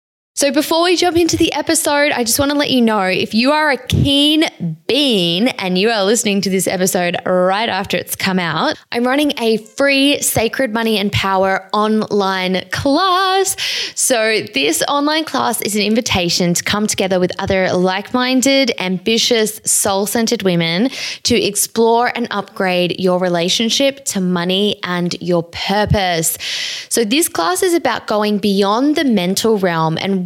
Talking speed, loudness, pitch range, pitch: 165 wpm, -15 LUFS, 185-275 Hz, 215 Hz